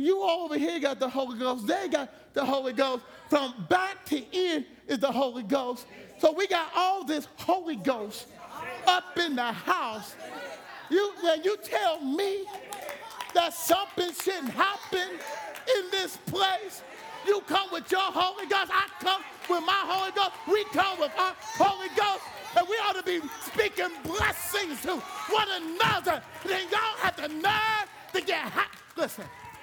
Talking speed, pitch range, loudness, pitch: 165 wpm, 310-390 Hz, -28 LUFS, 365 Hz